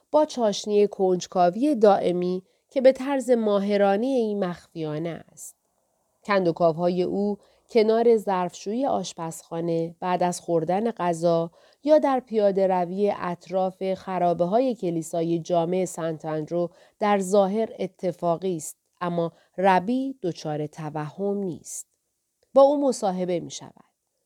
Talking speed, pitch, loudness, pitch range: 115 wpm, 185 Hz, -24 LUFS, 170-210 Hz